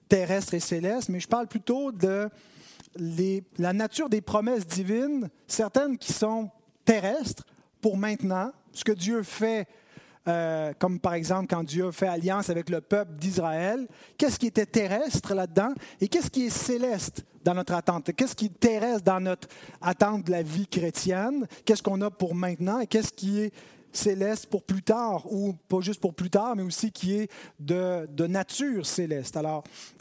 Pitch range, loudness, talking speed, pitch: 180-220 Hz, -28 LUFS, 175 wpm, 195 Hz